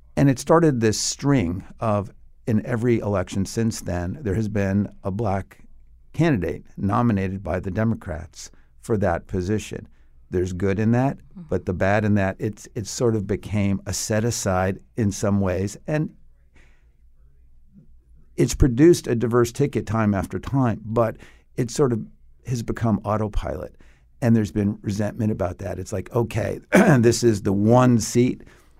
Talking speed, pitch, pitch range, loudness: 155 wpm, 100 Hz, 90-115 Hz, -22 LUFS